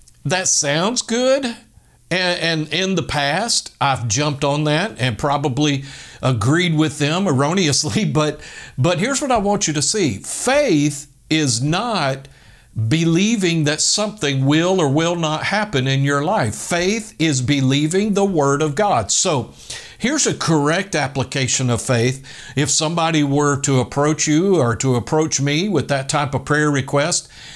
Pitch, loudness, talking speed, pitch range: 150 Hz, -18 LUFS, 155 wpm, 140-175 Hz